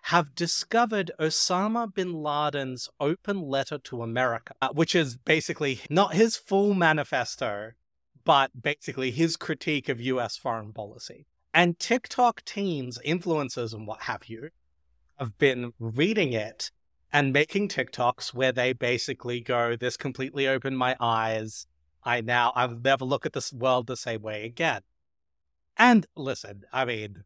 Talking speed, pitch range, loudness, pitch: 140 wpm, 120-160 Hz, -27 LUFS, 135 Hz